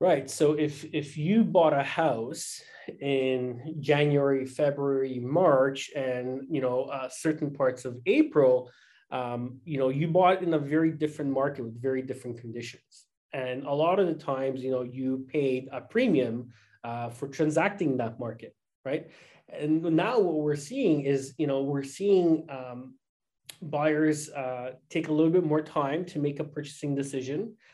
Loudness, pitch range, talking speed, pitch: -28 LUFS, 130-155 Hz, 165 wpm, 140 Hz